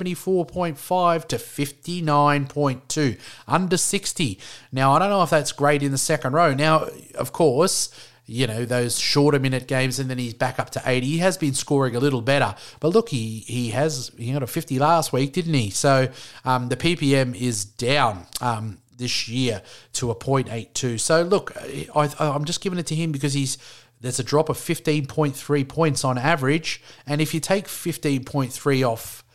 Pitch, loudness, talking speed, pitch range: 140 Hz, -22 LUFS, 185 wpm, 125-155 Hz